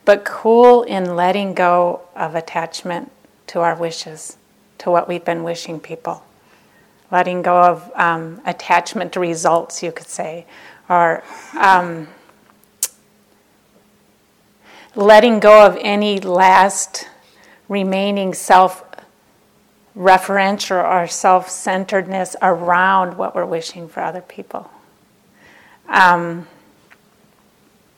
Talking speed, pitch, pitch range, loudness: 100 wpm, 180 Hz, 170-195 Hz, -15 LUFS